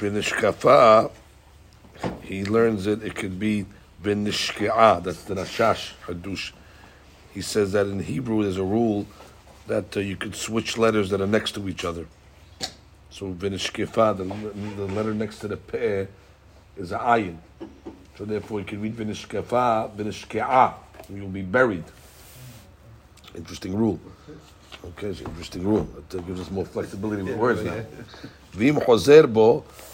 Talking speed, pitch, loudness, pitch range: 130 wpm, 100 Hz, -23 LUFS, 90-105 Hz